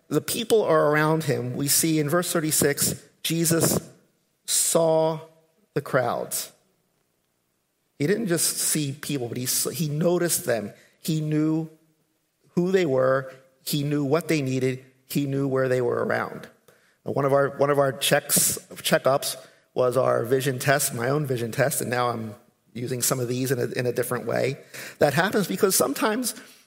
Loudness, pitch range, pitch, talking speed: -24 LUFS, 130-160 Hz, 150 Hz, 165 wpm